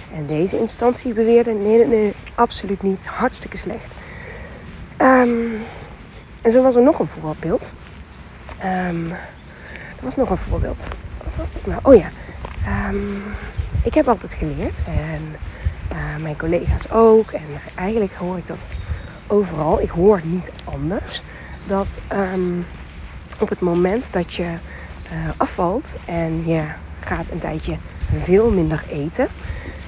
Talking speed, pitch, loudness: 135 wpm, 165 Hz, -20 LUFS